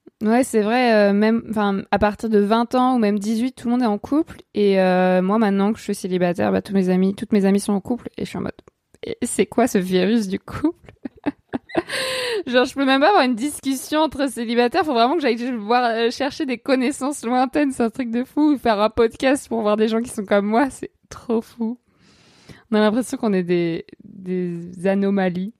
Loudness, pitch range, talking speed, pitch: -20 LUFS, 205-255 Hz, 225 wpm, 230 Hz